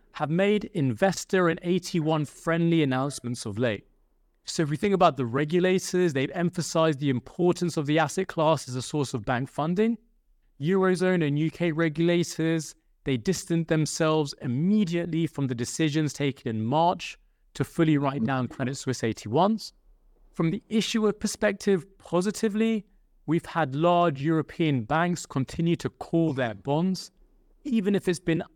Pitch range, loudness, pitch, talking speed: 140-180 Hz, -26 LUFS, 165 Hz, 145 wpm